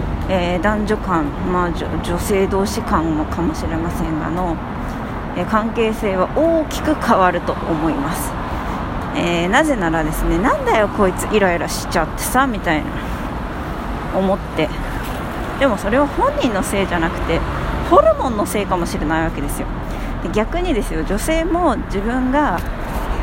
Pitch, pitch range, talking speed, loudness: 195 Hz, 165-255 Hz, 305 characters per minute, -19 LUFS